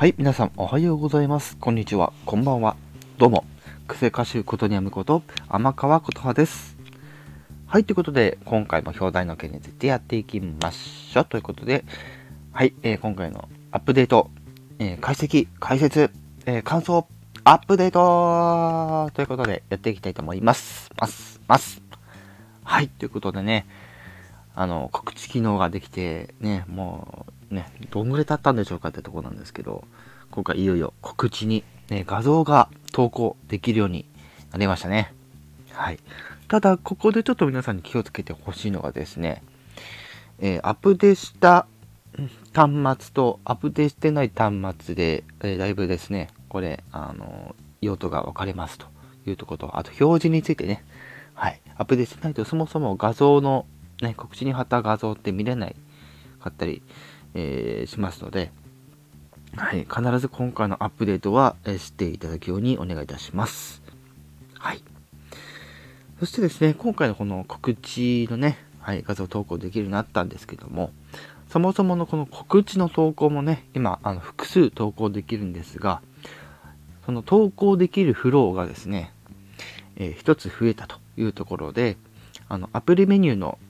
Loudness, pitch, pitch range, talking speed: -23 LUFS, 110 Hz, 95-135 Hz, 335 characters per minute